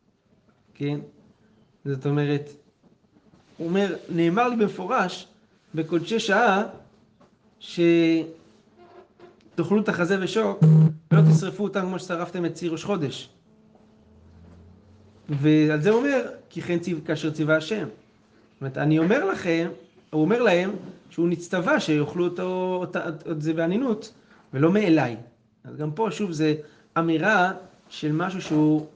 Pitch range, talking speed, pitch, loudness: 155-190 Hz, 120 wpm, 170 Hz, -24 LUFS